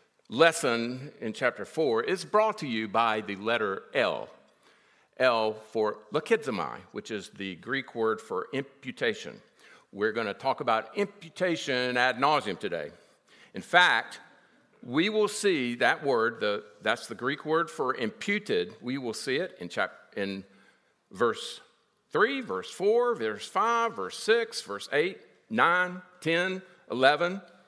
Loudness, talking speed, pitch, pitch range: -28 LUFS, 140 wpm, 140 Hz, 110-185 Hz